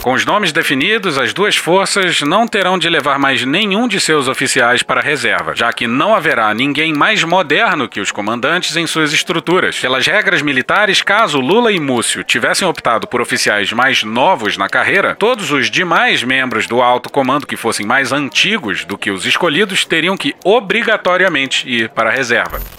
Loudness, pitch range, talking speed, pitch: -12 LUFS, 130-190 Hz, 180 wpm, 165 Hz